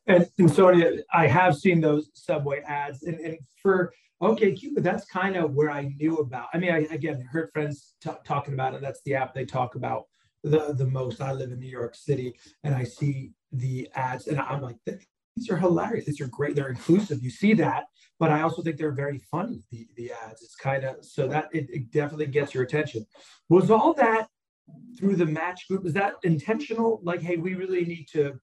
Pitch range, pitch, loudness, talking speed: 135-175 Hz, 150 Hz, -26 LUFS, 215 wpm